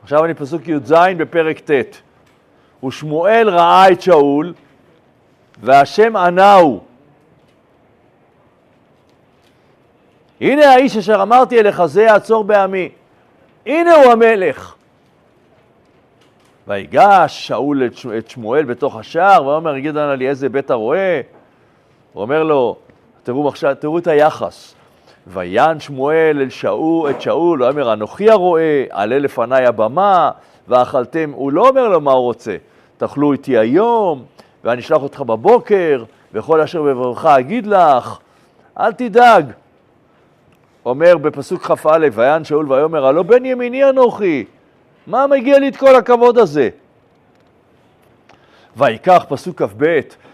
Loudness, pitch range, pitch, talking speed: -13 LUFS, 140-215 Hz, 160 Hz, 120 wpm